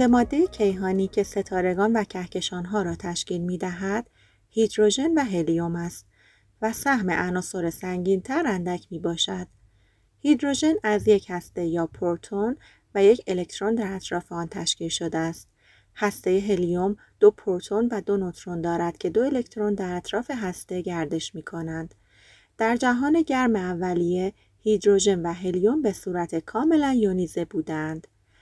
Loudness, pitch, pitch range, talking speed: -25 LUFS, 185 Hz, 170-210 Hz, 140 wpm